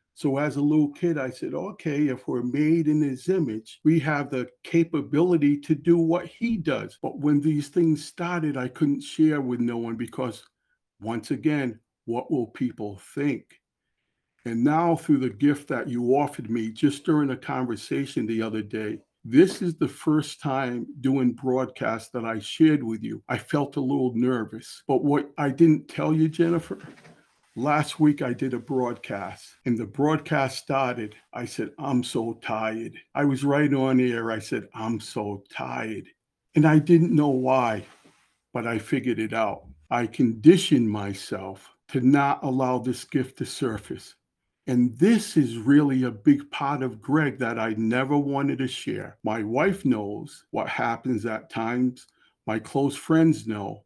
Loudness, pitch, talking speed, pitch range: -25 LUFS, 135 Hz, 170 wpm, 120-150 Hz